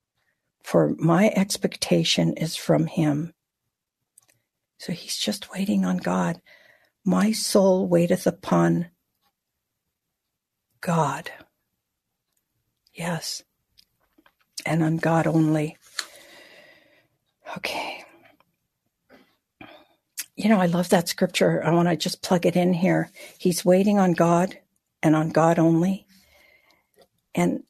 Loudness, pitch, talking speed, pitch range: -23 LUFS, 170 Hz, 100 wpm, 155-185 Hz